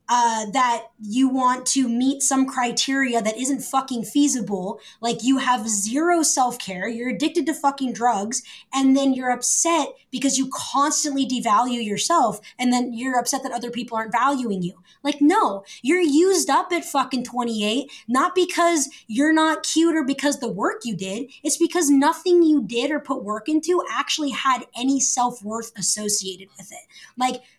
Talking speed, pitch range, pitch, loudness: 170 wpm, 235-290 Hz, 260 Hz, -21 LUFS